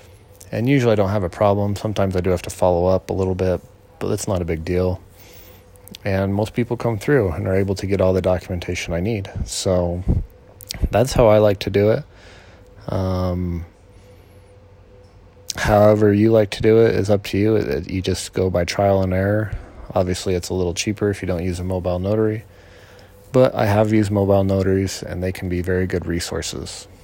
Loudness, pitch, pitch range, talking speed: -20 LUFS, 100 Hz, 90-105 Hz, 200 wpm